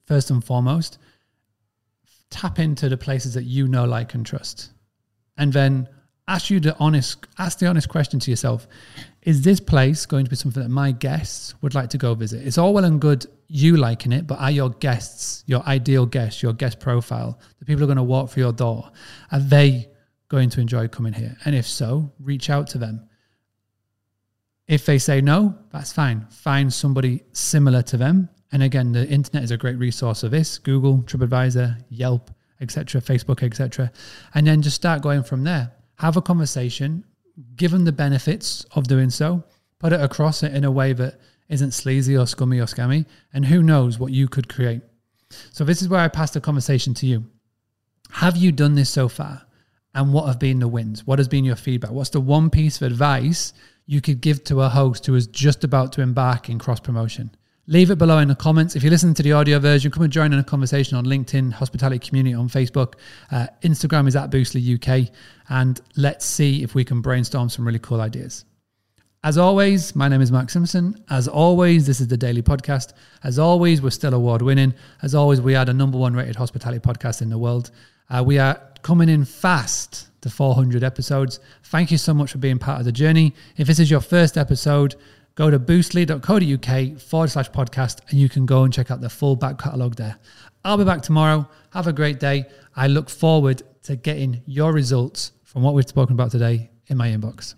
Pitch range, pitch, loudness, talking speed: 125-150 Hz, 135 Hz, -19 LUFS, 205 wpm